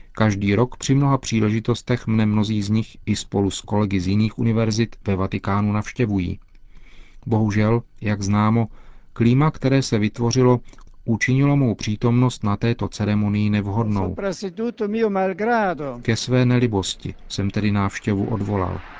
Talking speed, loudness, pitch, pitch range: 125 wpm, -21 LUFS, 110 Hz, 100-125 Hz